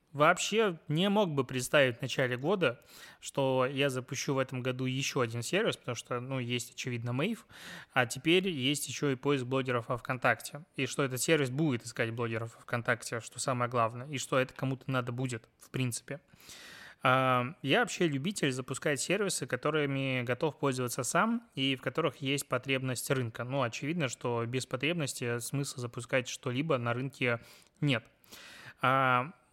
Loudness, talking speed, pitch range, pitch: -32 LUFS, 160 wpm, 125-145 Hz, 130 Hz